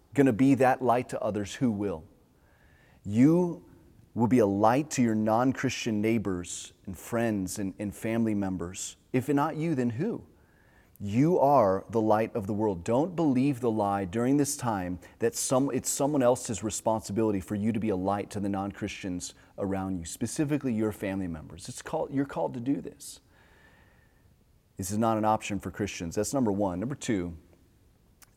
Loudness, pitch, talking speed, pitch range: -28 LUFS, 110 Hz, 175 wpm, 95-125 Hz